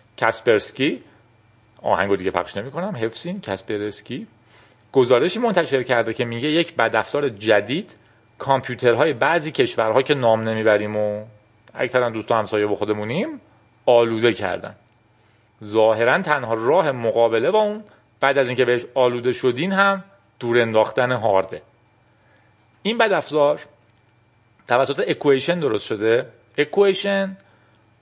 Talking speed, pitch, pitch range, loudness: 110 wpm, 120 Hz, 110-145 Hz, -20 LUFS